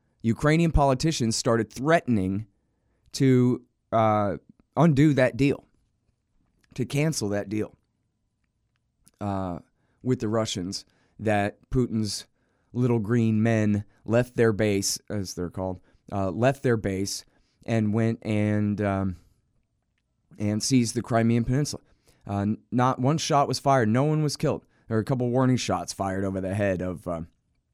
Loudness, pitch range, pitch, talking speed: -25 LUFS, 100-125 Hz, 115 Hz, 135 wpm